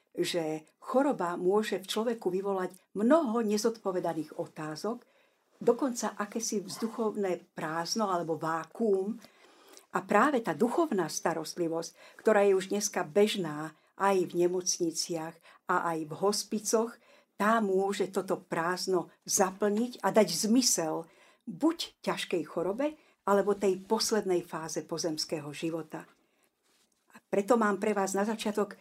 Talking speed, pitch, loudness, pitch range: 115 wpm, 195 Hz, -30 LUFS, 170-220 Hz